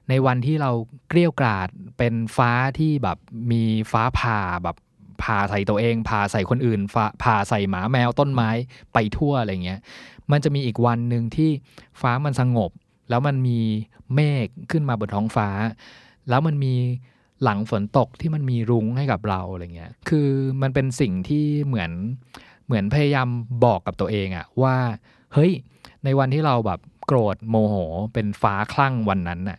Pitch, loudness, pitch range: 120 Hz, -22 LUFS, 105-135 Hz